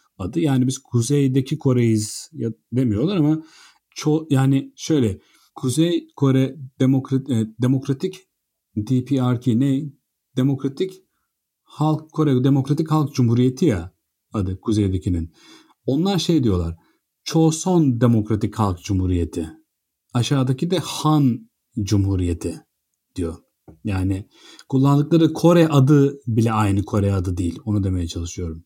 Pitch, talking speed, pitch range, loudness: 130 Hz, 105 wpm, 105-145 Hz, -20 LUFS